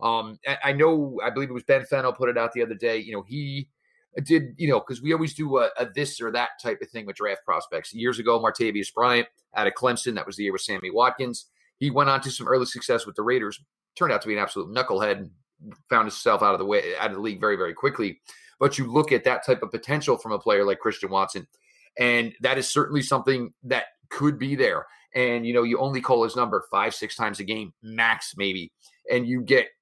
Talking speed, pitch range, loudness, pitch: 245 wpm, 115-140 Hz, -24 LUFS, 125 Hz